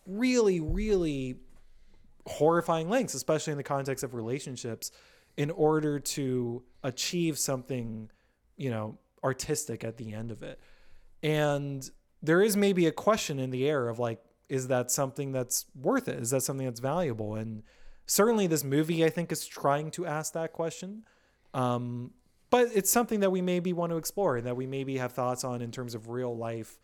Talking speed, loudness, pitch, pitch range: 175 wpm, -30 LUFS, 140 Hz, 125-165 Hz